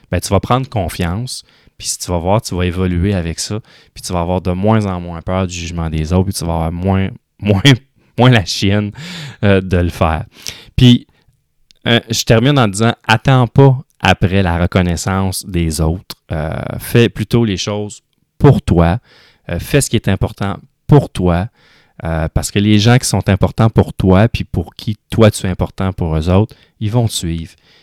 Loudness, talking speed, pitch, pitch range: -14 LUFS, 200 wpm, 100 Hz, 90-115 Hz